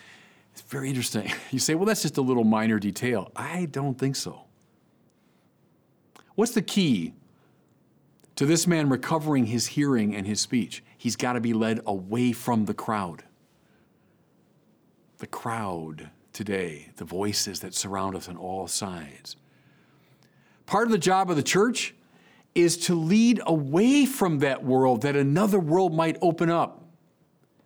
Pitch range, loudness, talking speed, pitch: 105-170 Hz, -25 LUFS, 150 wpm, 130 Hz